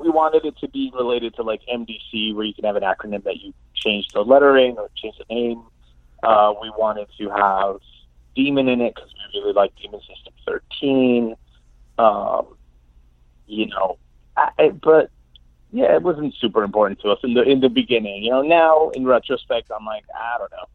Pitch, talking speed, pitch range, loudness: 110 Hz, 195 wpm, 95-130 Hz, -19 LUFS